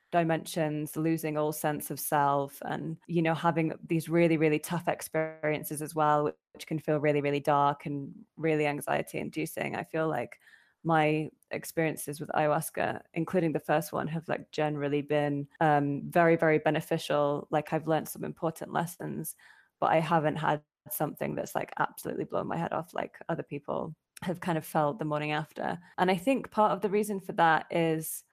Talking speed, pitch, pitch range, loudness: 180 wpm, 155 Hz, 150-165 Hz, -30 LUFS